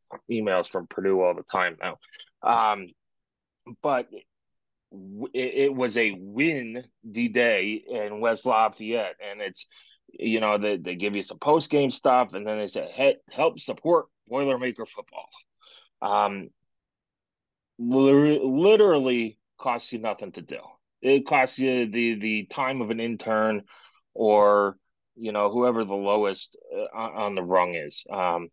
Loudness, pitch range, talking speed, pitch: -25 LUFS, 105-130 Hz, 135 wpm, 115 Hz